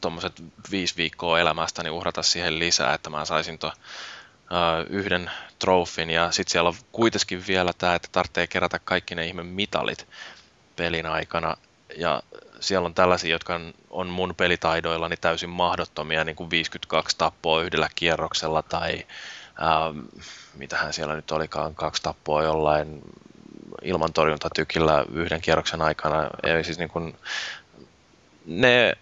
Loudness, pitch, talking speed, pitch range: -24 LUFS, 85 Hz, 135 wpm, 80-90 Hz